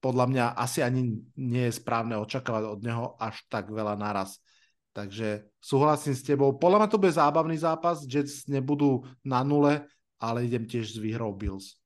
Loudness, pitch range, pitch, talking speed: -28 LUFS, 110-145 Hz, 125 Hz, 170 wpm